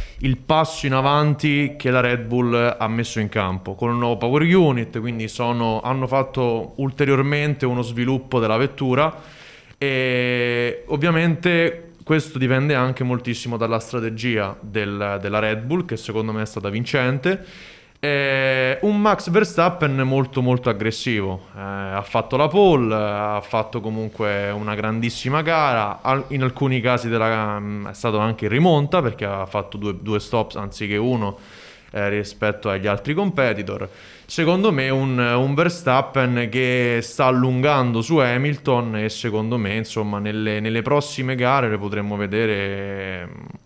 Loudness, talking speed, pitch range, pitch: -21 LUFS, 150 wpm, 110-135 Hz, 120 Hz